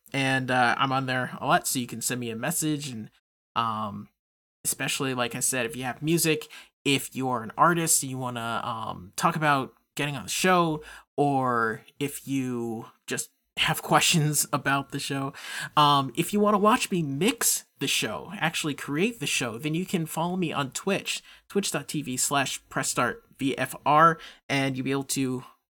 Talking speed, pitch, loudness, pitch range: 180 wpm, 135 Hz, -26 LUFS, 125-155 Hz